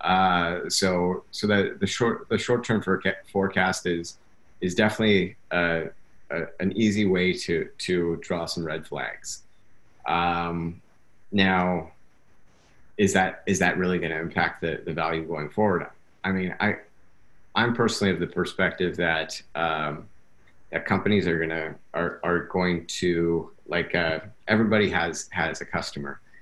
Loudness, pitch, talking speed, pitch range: -25 LUFS, 90 Hz, 145 wpm, 85-95 Hz